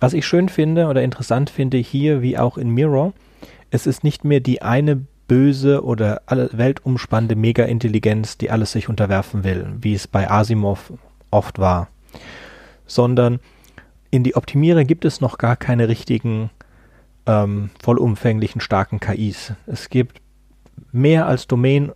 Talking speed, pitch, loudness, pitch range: 140 wpm, 120 Hz, -18 LUFS, 110-135 Hz